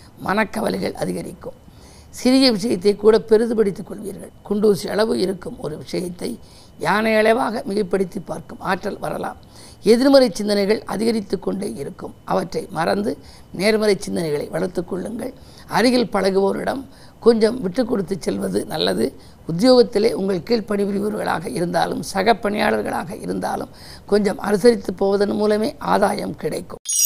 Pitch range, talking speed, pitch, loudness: 195-225 Hz, 105 wpm, 210 Hz, -20 LUFS